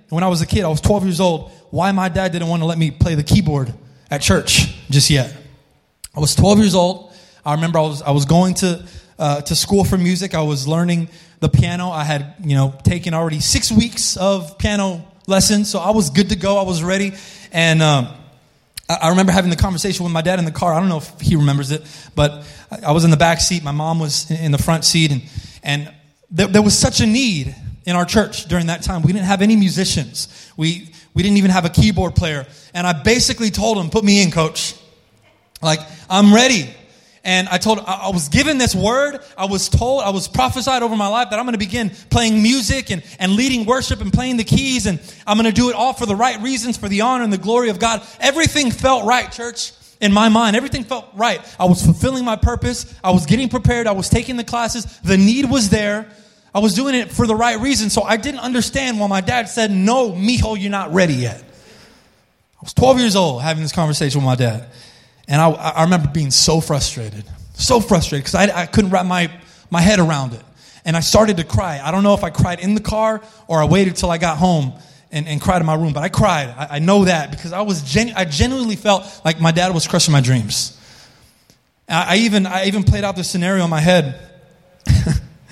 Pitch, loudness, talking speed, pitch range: 180 Hz, -16 LUFS, 235 wpm, 155-210 Hz